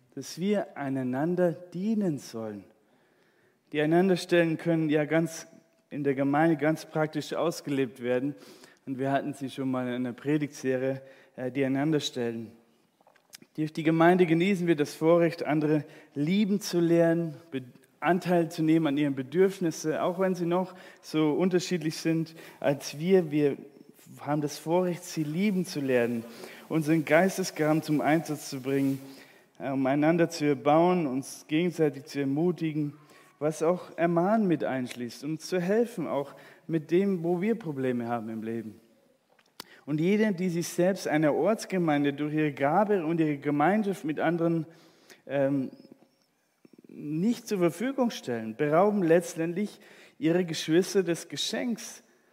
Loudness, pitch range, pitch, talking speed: -28 LUFS, 140-175 Hz, 155 Hz, 135 wpm